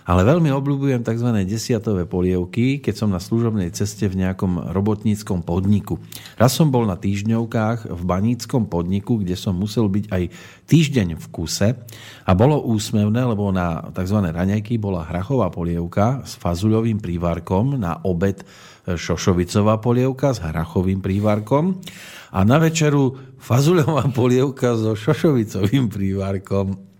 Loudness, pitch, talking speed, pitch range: -20 LUFS, 105 Hz, 130 wpm, 95-125 Hz